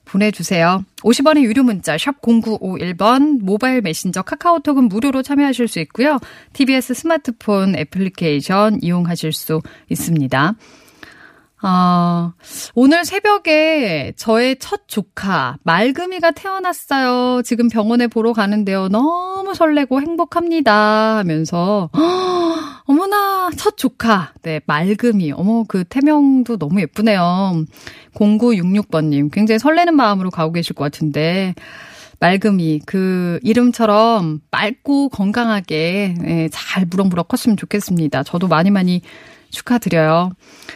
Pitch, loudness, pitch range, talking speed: 210 Hz, -16 LUFS, 175-265 Hz, 270 characters per minute